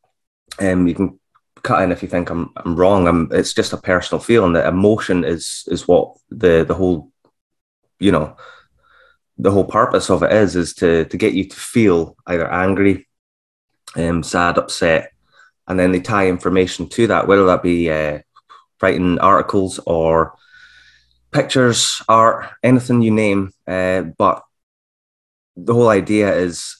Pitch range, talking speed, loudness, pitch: 85-100 Hz, 160 wpm, -16 LUFS, 90 Hz